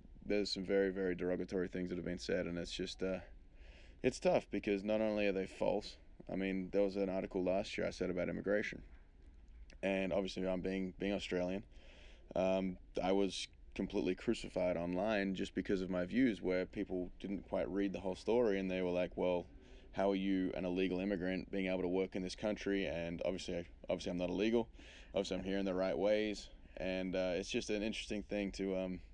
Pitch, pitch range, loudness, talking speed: 95 Hz, 90-100 Hz, -39 LUFS, 205 wpm